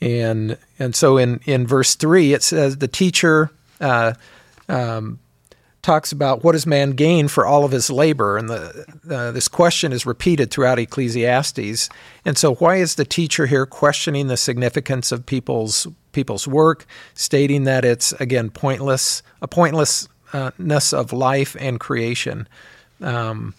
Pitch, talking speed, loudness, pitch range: 135 Hz, 150 wpm, -18 LUFS, 125-150 Hz